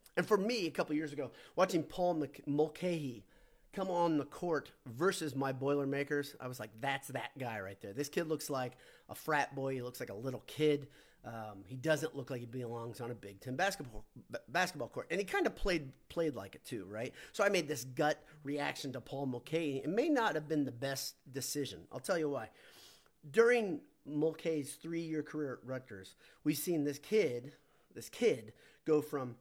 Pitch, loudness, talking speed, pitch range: 145 Hz, -37 LUFS, 200 wpm, 130-160 Hz